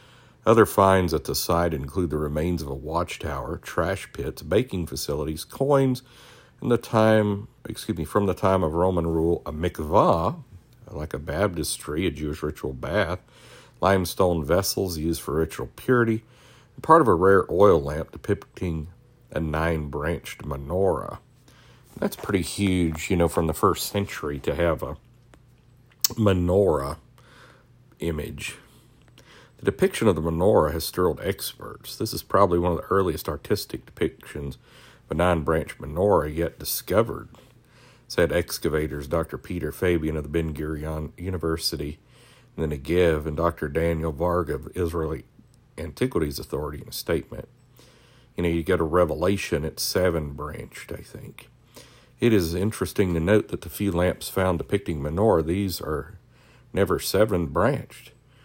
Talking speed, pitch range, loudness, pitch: 145 wpm, 80-110 Hz, -24 LUFS, 90 Hz